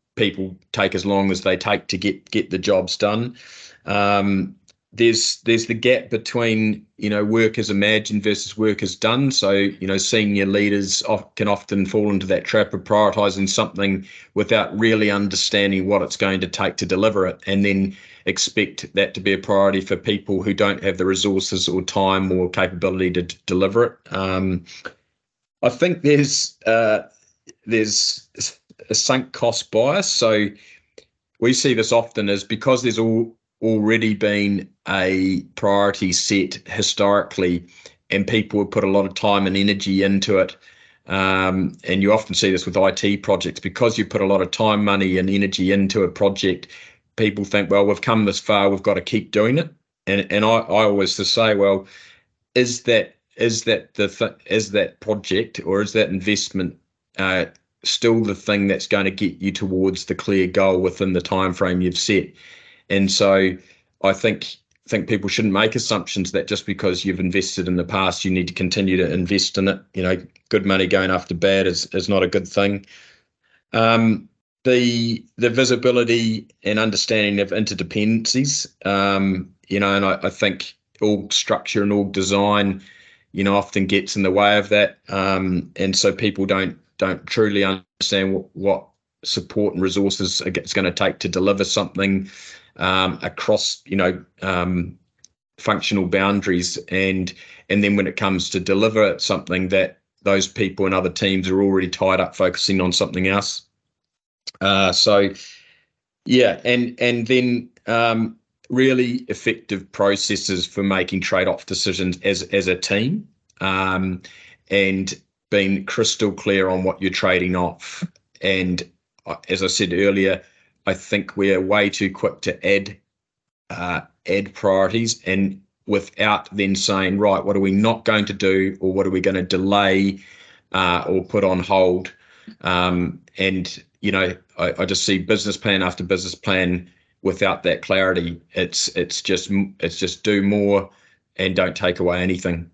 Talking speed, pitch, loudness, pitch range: 170 wpm, 100 Hz, -20 LUFS, 95-105 Hz